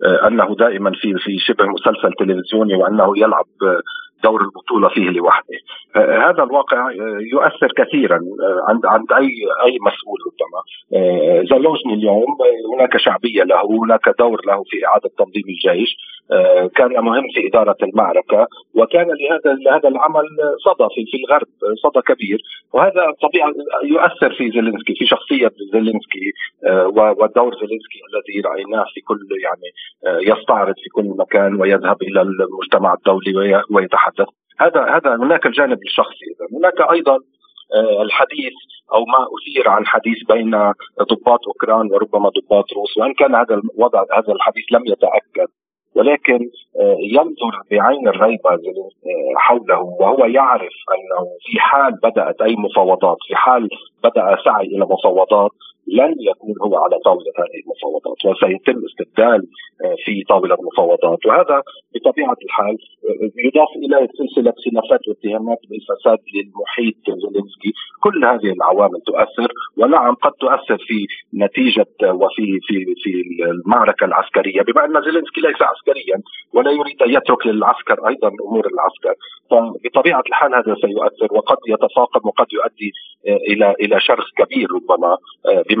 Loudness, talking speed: -15 LUFS, 130 wpm